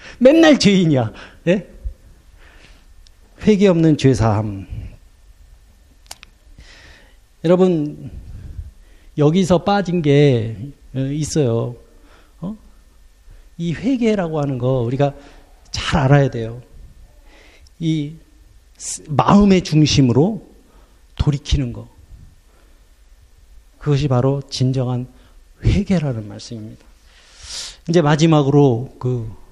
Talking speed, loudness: 165 characters per minute, -17 LUFS